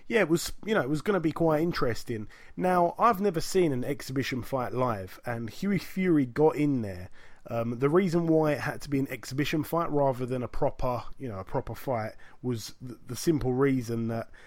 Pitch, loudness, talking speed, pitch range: 135 Hz, -29 LUFS, 210 wpm, 120-160 Hz